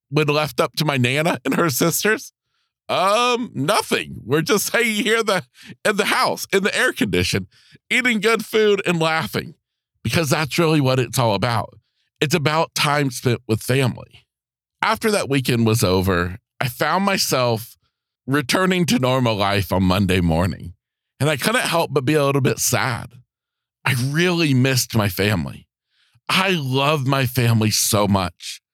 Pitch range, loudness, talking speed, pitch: 115-170 Hz, -19 LUFS, 165 wpm, 140 Hz